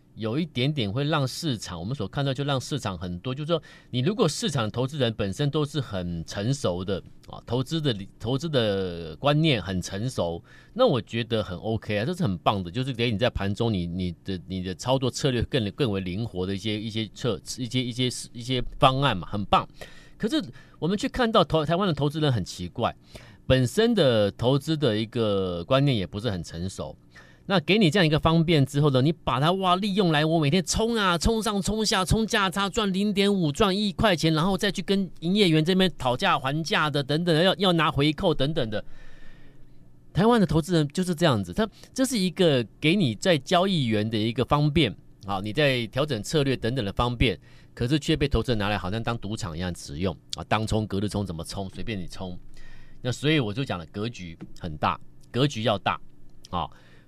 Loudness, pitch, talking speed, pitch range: -25 LUFS, 130 Hz, 300 characters per minute, 105-165 Hz